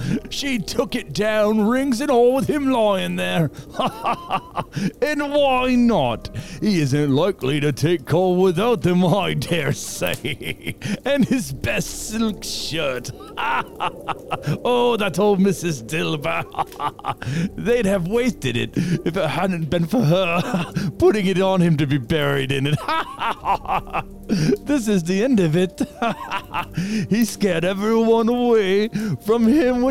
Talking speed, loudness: 135 wpm, -20 LUFS